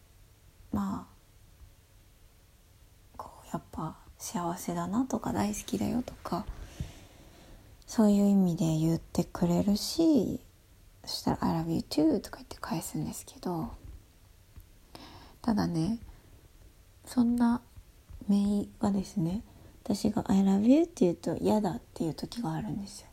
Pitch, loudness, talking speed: 125 Hz, -30 LUFS, 265 characters per minute